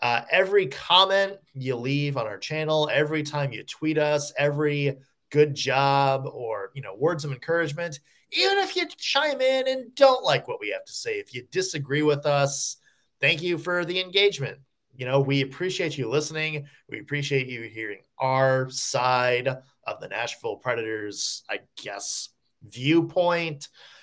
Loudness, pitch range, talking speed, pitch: -25 LUFS, 135-175 Hz, 160 wpm, 145 Hz